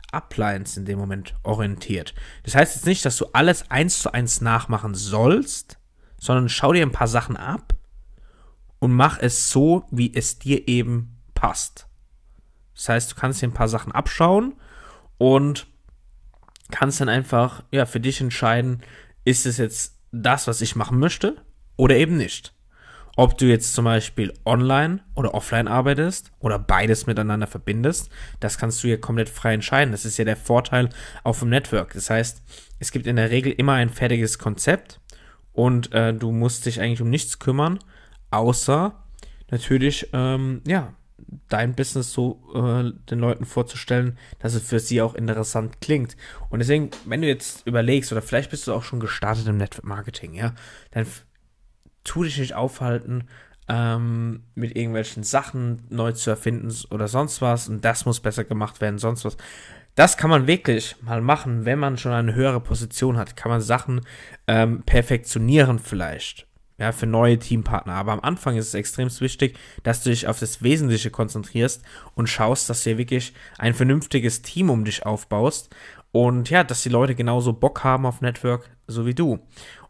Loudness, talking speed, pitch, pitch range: -22 LUFS, 170 wpm, 120 Hz, 115-130 Hz